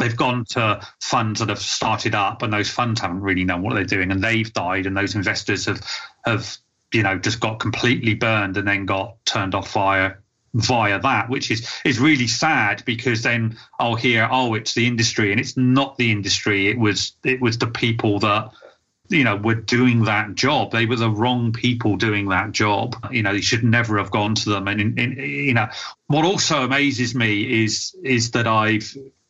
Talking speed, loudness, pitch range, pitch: 210 wpm, -20 LUFS, 105-125 Hz, 115 Hz